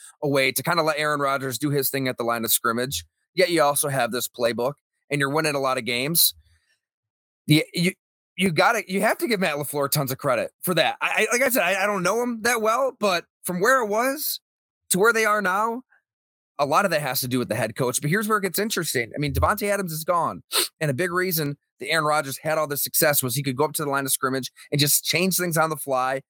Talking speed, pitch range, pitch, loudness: 265 wpm, 135-185 Hz, 150 Hz, -22 LUFS